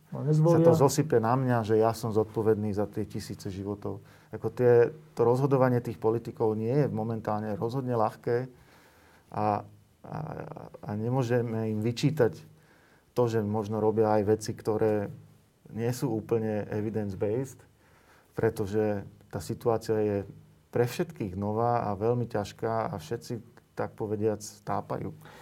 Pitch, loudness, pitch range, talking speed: 110 Hz, -29 LUFS, 105-120 Hz, 130 wpm